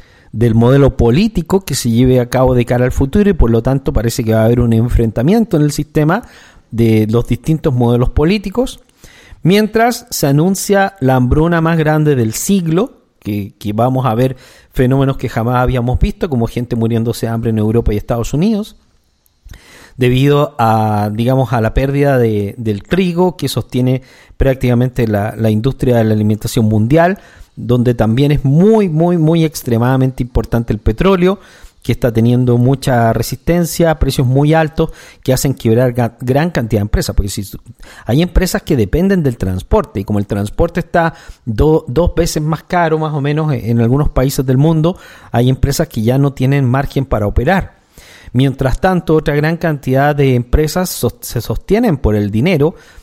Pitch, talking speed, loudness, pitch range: 130 Hz, 175 wpm, -13 LUFS, 115-160 Hz